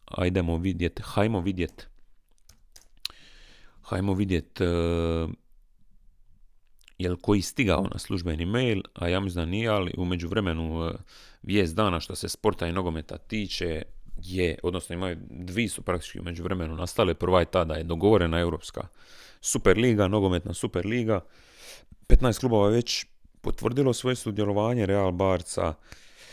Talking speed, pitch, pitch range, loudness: 130 wpm, 95 Hz, 85-105 Hz, -27 LUFS